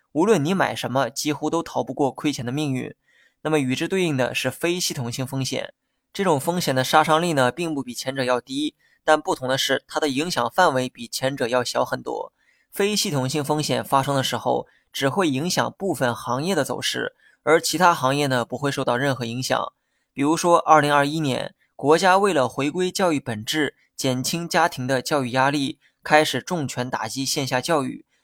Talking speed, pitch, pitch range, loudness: 295 characters per minute, 140 Hz, 130-160 Hz, -22 LUFS